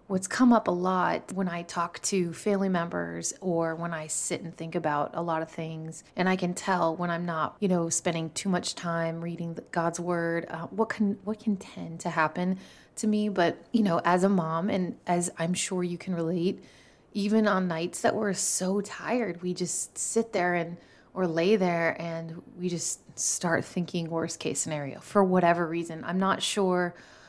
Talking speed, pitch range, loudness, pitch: 200 wpm, 165-190 Hz, -28 LUFS, 175 Hz